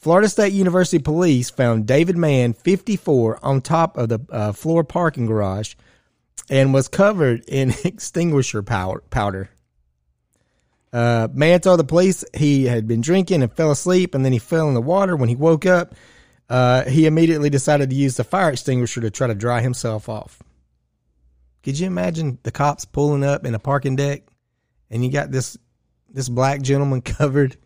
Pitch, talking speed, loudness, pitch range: 135 Hz, 170 wpm, -19 LUFS, 115-160 Hz